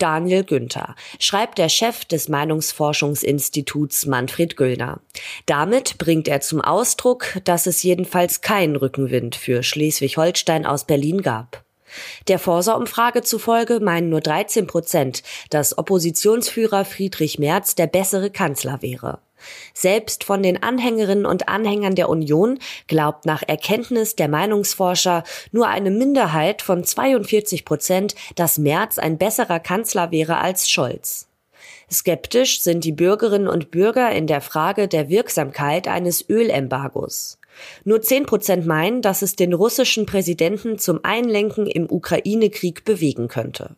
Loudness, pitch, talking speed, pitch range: -19 LUFS, 180 Hz, 130 wpm, 155-210 Hz